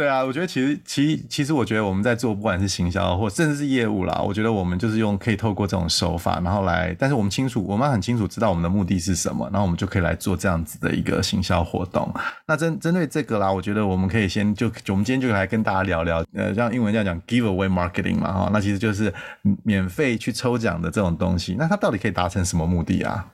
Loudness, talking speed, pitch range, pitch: -22 LUFS, 435 characters per minute, 95-120 Hz, 100 Hz